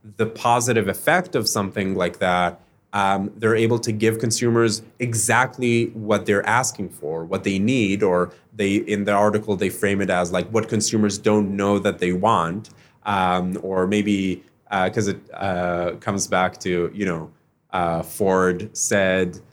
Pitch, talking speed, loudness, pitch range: 100 Hz, 165 wpm, -21 LUFS, 90-110 Hz